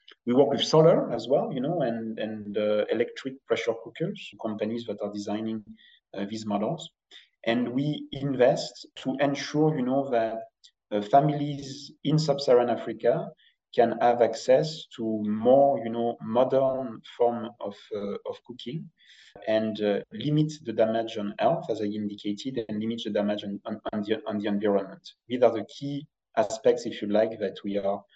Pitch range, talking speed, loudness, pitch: 105-140 Hz, 165 wpm, -27 LUFS, 115 Hz